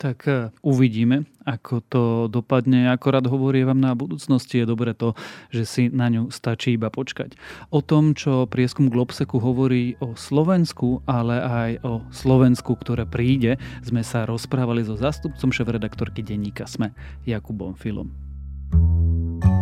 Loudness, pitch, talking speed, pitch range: -22 LUFS, 125 Hz, 135 wpm, 115-130 Hz